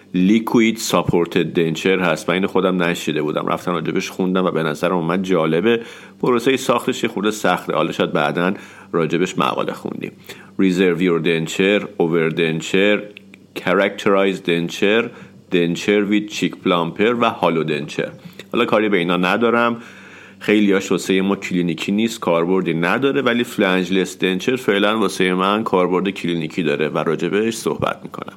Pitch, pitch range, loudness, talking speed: 95 Hz, 90-105 Hz, -18 LUFS, 145 wpm